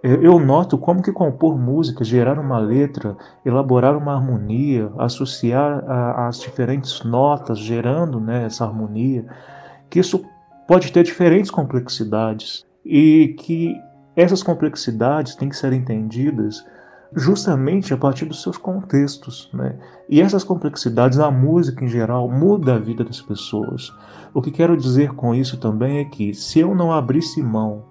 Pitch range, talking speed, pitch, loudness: 120-160 Hz, 145 wpm, 135 Hz, -18 LUFS